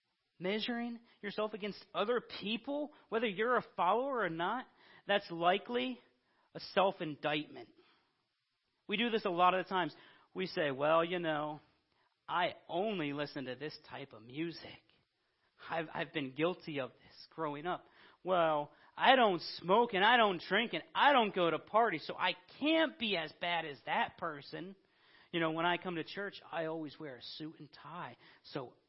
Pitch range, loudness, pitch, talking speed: 155-215 Hz, -35 LUFS, 175 Hz, 170 wpm